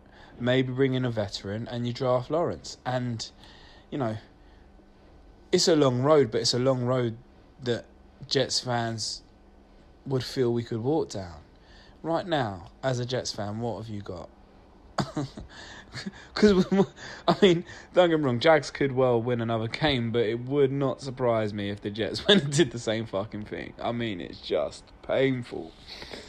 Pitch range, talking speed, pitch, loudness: 105-140 Hz, 170 wpm, 120 Hz, -27 LUFS